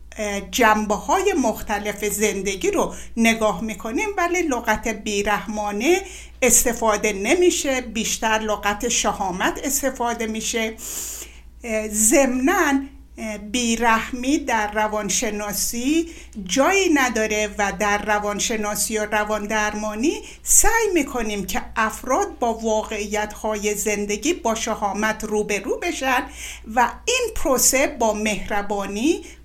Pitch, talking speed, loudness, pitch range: 220 Hz, 90 wpm, -21 LUFS, 210-265 Hz